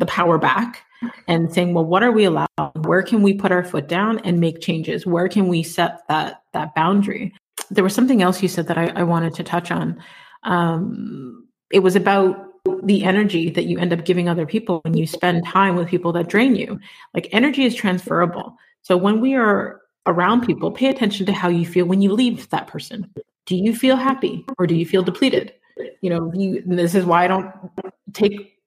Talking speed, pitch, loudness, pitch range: 210 wpm, 185 Hz, -19 LUFS, 175-210 Hz